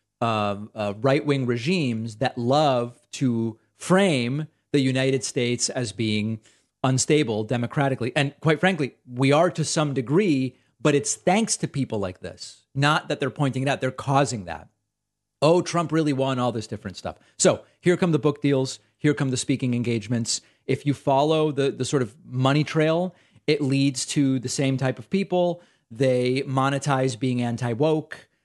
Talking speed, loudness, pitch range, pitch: 170 wpm, -24 LUFS, 120-150 Hz, 135 Hz